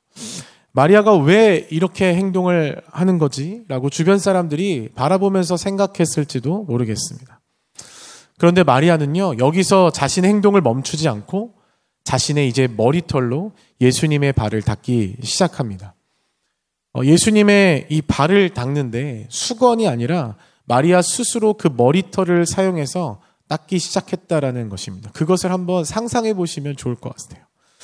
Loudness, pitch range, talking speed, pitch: -17 LUFS, 130-190 Hz, 310 characters per minute, 165 Hz